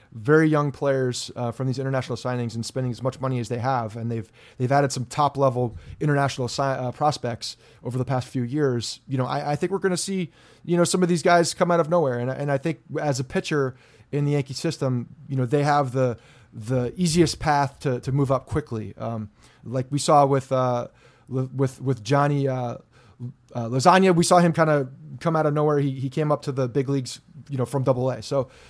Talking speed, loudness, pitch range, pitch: 230 wpm, -24 LUFS, 125-145 Hz, 135 Hz